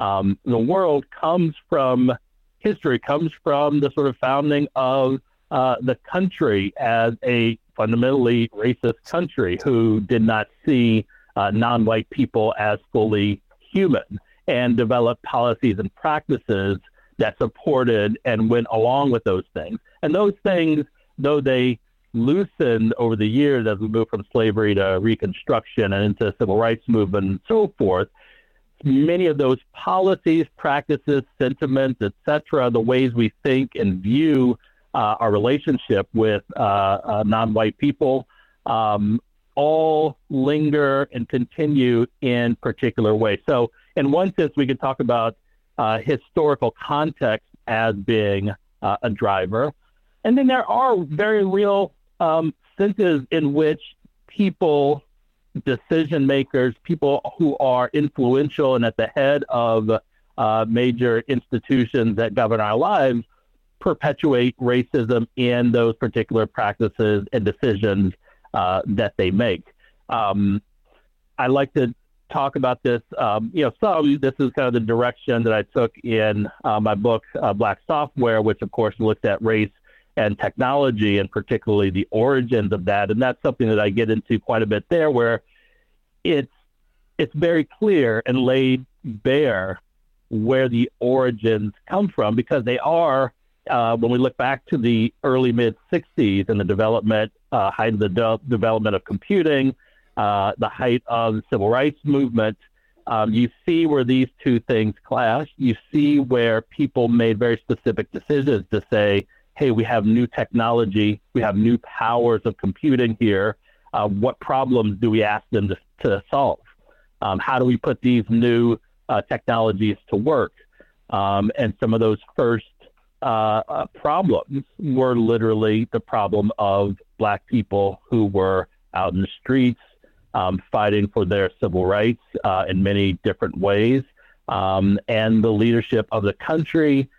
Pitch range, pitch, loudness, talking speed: 110-135 Hz, 120 Hz, -21 LUFS, 150 wpm